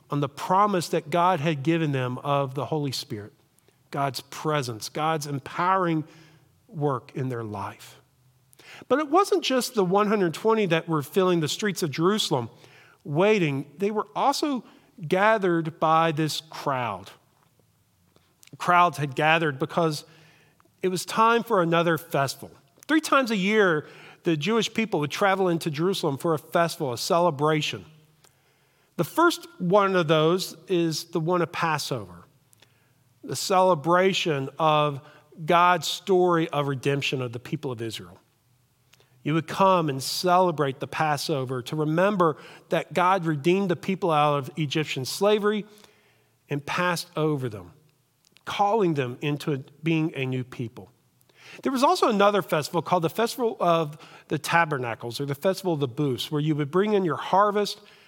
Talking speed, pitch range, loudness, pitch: 145 wpm, 140-180 Hz, -24 LUFS, 160 Hz